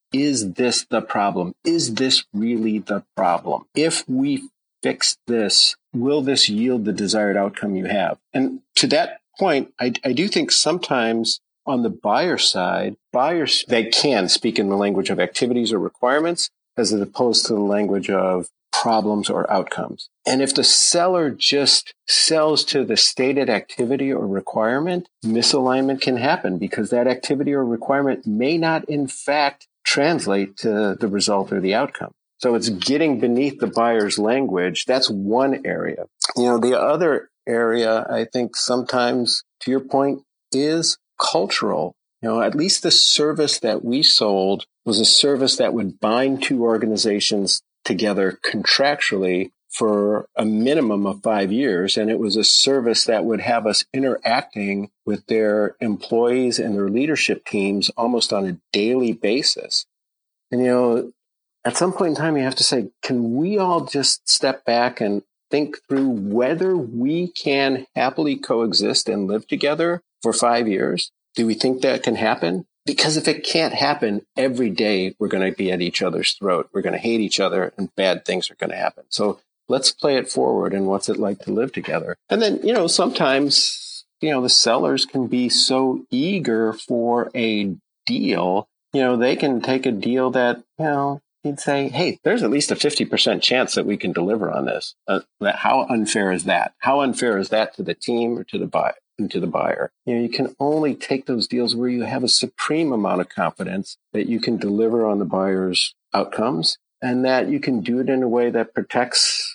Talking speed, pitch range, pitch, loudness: 180 wpm, 110-140 Hz, 125 Hz, -19 LUFS